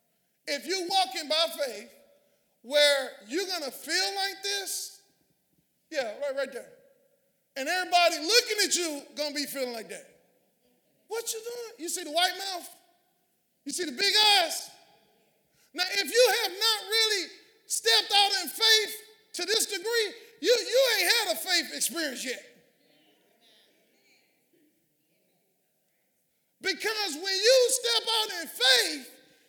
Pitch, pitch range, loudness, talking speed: 370 Hz, 310-435 Hz, -26 LUFS, 135 wpm